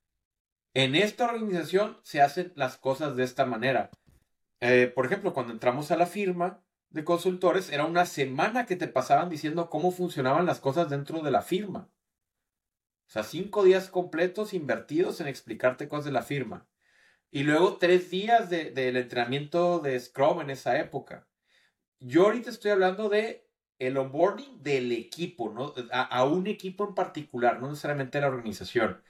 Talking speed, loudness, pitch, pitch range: 165 wpm, -28 LUFS, 170 Hz, 135-185 Hz